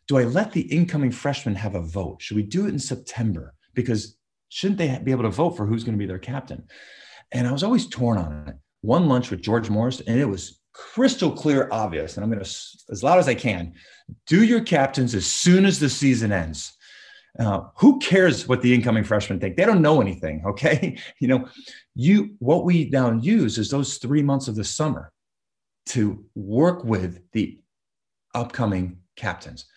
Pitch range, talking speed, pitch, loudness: 105-150 Hz, 200 wpm, 125 Hz, -22 LUFS